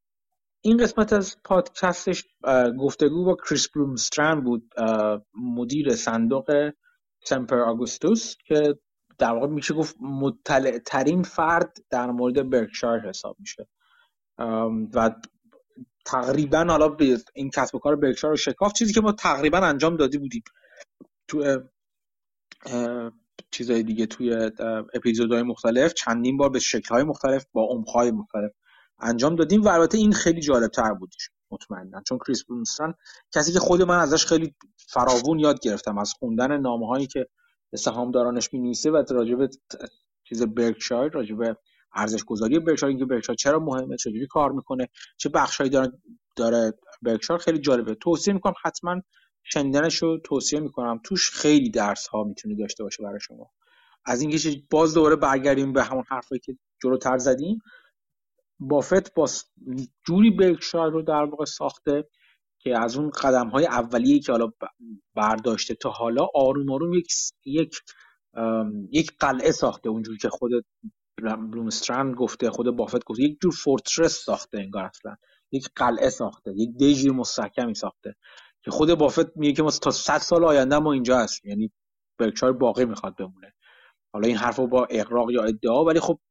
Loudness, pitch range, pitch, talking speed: -23 LUFS, 120-165 Hz, 135 Hz, 150 wpm